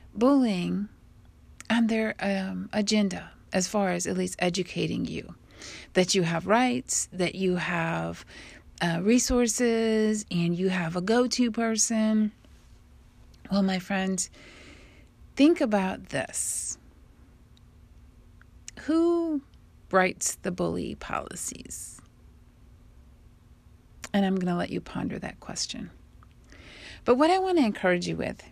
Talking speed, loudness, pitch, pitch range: 120 wpm, -27 LUFS, 190 Hz, 170-225 Hz